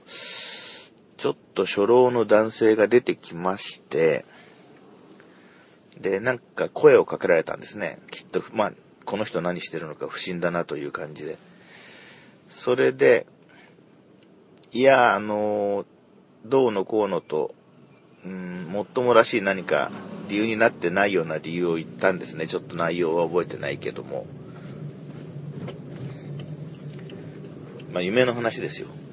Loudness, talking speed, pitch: -24 LUFS, 255 characters per minute, 150 Hz